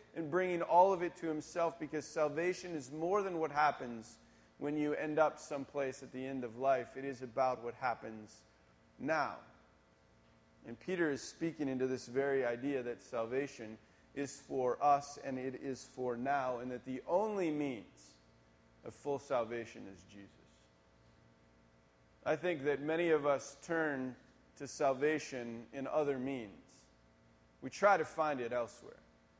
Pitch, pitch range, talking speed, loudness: 130 Hz, 100-150 Hz, 155 wpm, -37 LUFS